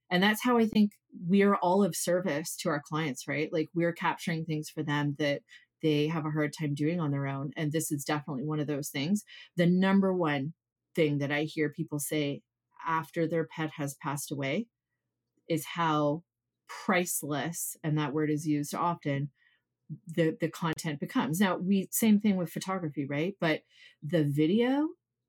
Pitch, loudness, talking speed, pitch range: 160 Hz, -30 LUFS, 180 wpm, 150-175 Hz